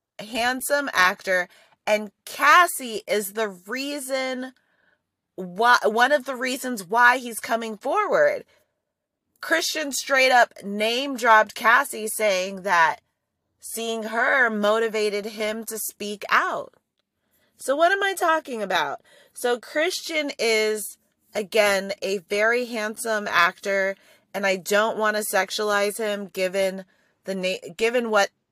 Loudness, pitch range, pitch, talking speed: -22 LUFS, 205-255 Hz, 220 Hz, 120 wpm